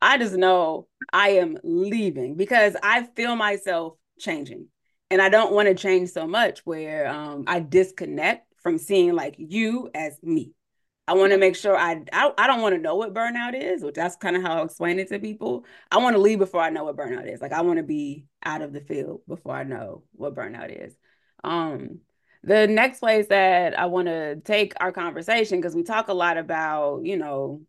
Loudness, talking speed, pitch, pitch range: -22 LUFS, 210 wpm, 185 Hz, 165-215 Hz